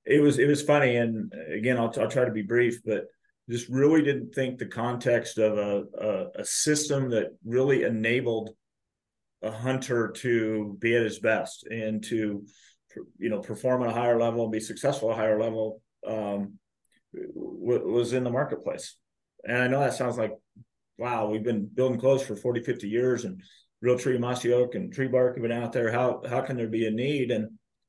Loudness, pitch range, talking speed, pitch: -27 LUFS, 110-130 Hz, 195 wpm, 120 Hz